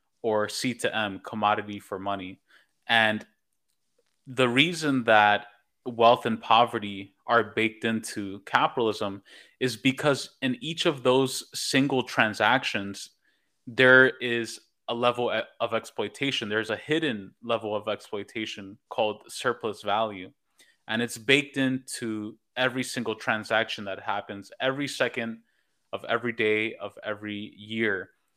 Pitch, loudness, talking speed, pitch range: 115 Hz, -26 LUFS, 125 wpm, 105-130 Hz